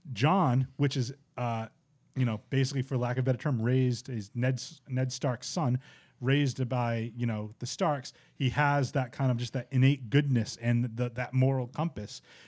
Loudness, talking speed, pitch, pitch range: -30 LUFS, 190 wpm, 130 Hz, 120-140 Hz